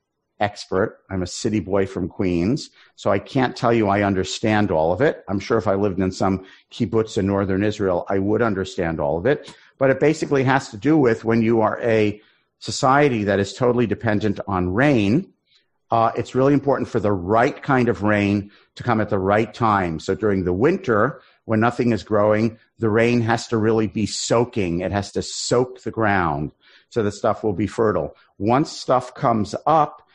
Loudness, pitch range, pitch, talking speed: -21 LUFS, 100-115 Hz, 110 Hz, 195 wpm